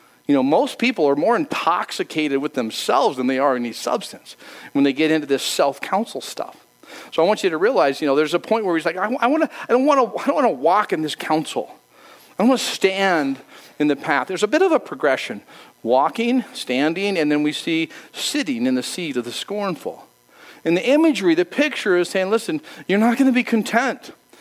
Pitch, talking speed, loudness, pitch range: 200 Hz, 225 wpm, -20 LUFS, 155-260 Hz